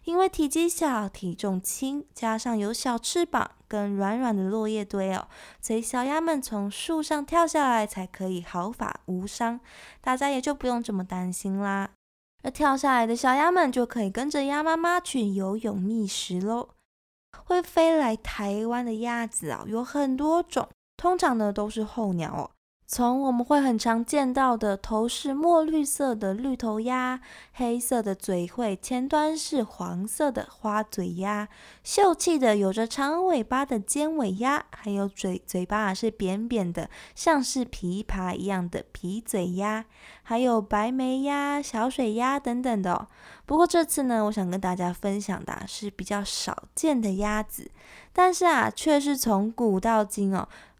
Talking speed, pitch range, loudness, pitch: 235 characters per minute, 200-280 Hz, -27 LUFS, 230 Hz